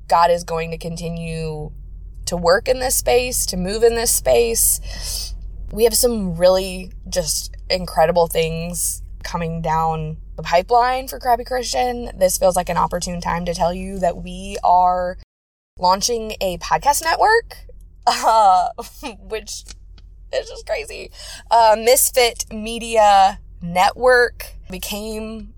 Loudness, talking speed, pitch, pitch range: -18 LUFS, 130 wpm, 180 Hz, 160-230 Hz